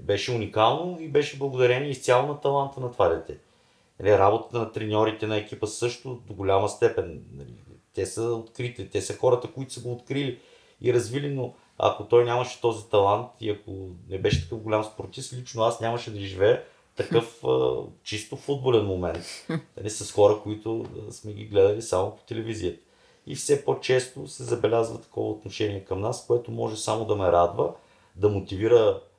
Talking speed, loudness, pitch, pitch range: 165 wpm, -26 LUFS, 115 Hz, 105-130 Hz